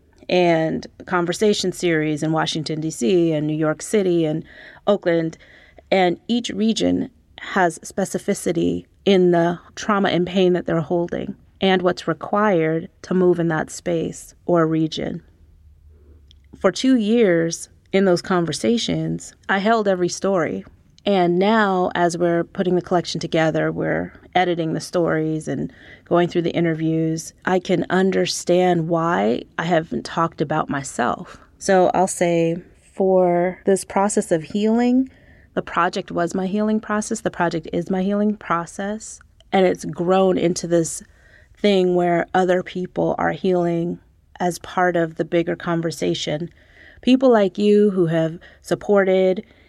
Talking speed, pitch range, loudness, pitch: 140 wpm, 160-190 Hz, -20 LUFS, 175 Hz